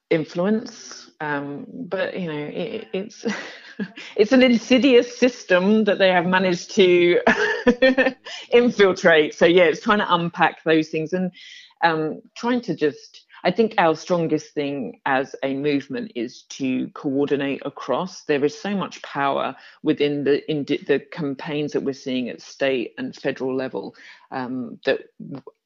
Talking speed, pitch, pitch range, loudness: 145 wpm, 180 Hz, 150-235 Hz, -21 LUFS